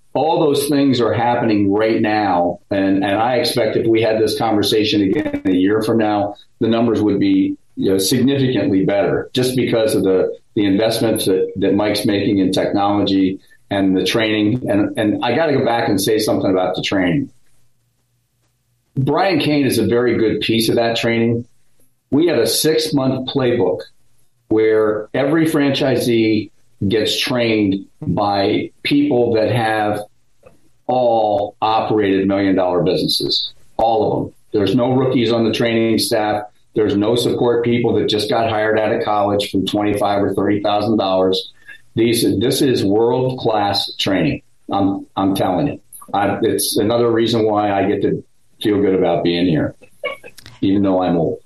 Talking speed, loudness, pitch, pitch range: 165 wpm, -17 LUFS, 110 Hz, 100-120 Hz